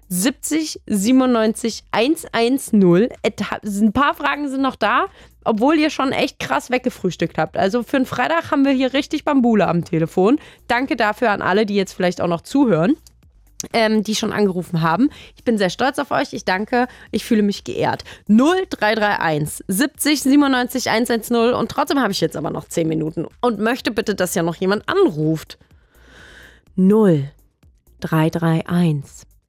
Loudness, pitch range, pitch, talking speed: -18 LUFS, 180-265 Hz, 220 Hz, 155 wpm